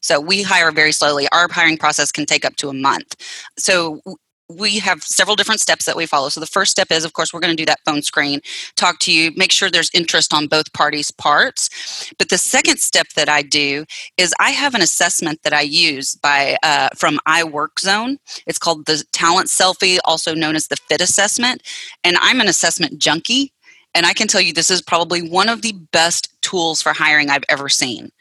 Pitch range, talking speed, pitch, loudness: 150-190 Hz, 215 wpm, 165 Hz, -15 LUFS